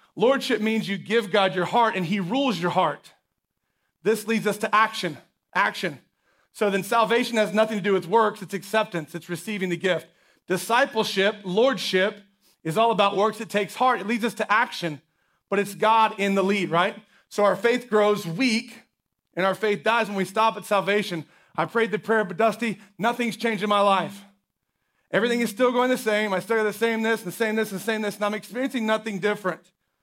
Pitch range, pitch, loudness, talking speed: 190-225 Hz, 210 Hz, -24 LUFS, 210 wpm